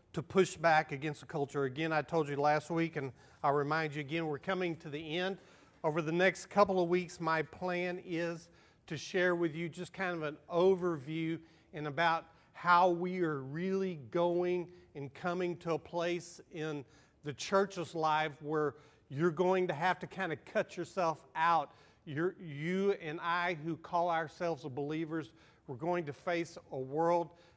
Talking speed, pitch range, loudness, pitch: 175 wpm, 155-180 Hz, -35 LUFS, 165 Hz